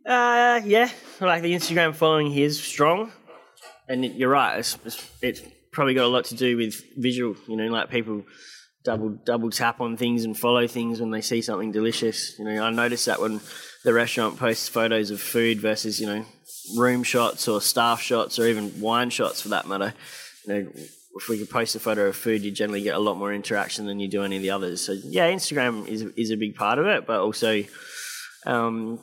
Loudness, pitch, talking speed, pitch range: -24 LUFS, 115 Hz, 215 wpm, 110-125 Hz